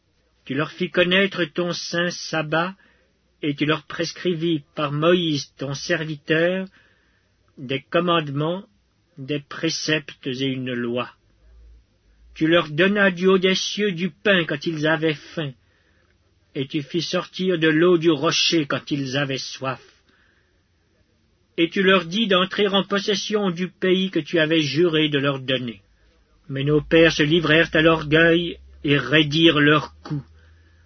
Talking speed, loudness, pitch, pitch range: 145 wpm, -21 LUFS, 155 Hz, 130-175 Hz